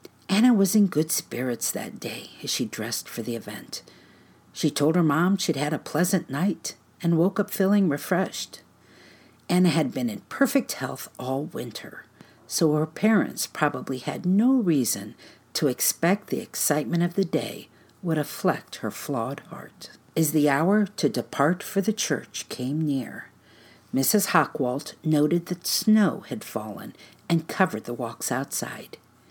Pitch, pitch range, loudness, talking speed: 155 Hz, 135-195 Hz, -25 LUFS, 155 wpm